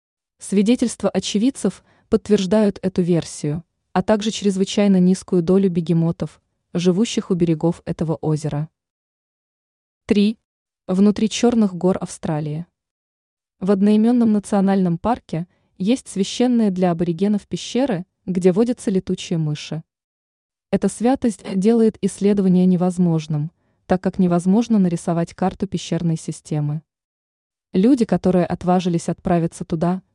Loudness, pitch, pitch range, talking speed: -19 LUFS, 185 Hz, 170-205 Hz, 100 wpm